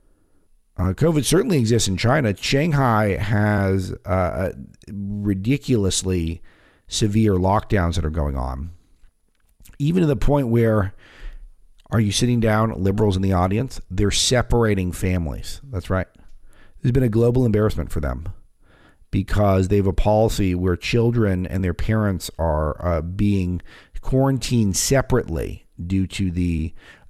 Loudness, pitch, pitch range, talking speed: -21 LUFS, 100 Hz, 90-115 Hz, 130 wpm